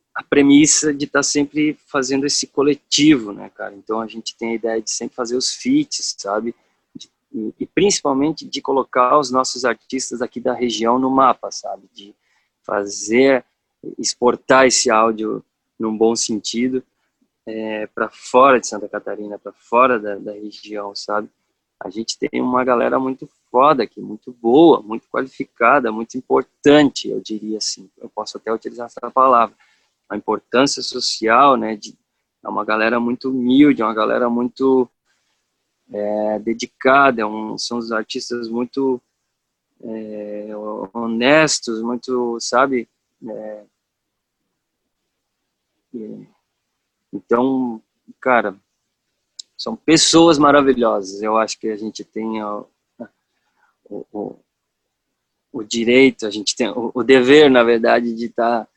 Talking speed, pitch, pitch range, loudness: 135 wpm, 120 Hz, 110-130 Hz, -17 LUFS